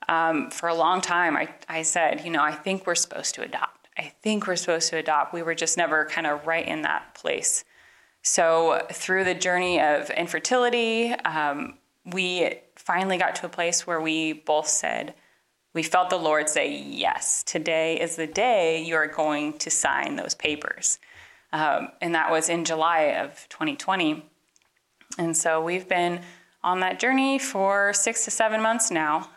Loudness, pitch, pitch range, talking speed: -24 LUFS, 170 Hz, 160-190 Hz, 180 wpm